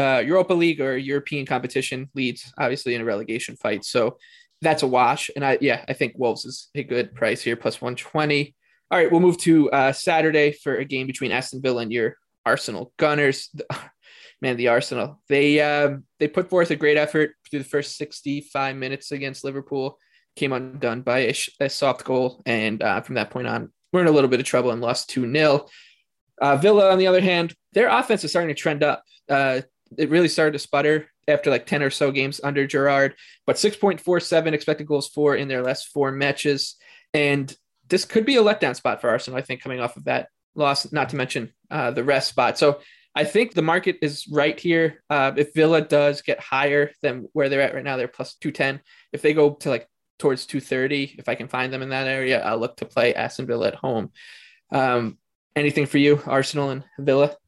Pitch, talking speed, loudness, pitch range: 140 Hz, 210 wpm, -22 LUFS, 130-155 Hz